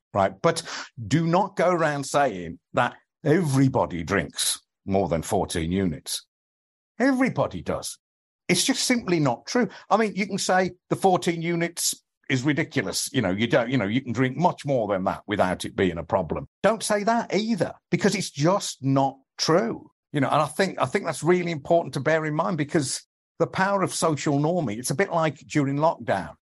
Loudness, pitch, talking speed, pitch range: -24 LUFS, 160 Hz, 190 wpm, 135-180 Hz